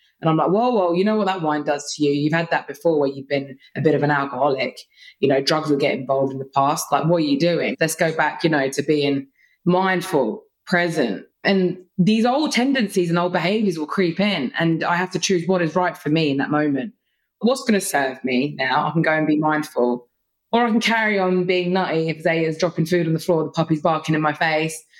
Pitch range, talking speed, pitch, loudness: 145-185 Hz, 245 wpm, 160 Hz, -20 LUFS